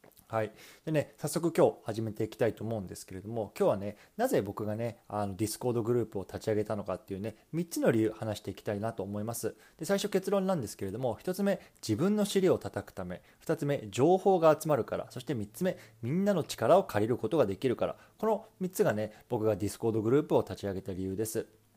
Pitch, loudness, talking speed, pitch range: 115 Hz, -32 LUFS, 440 characters per minute, 105-160 Hz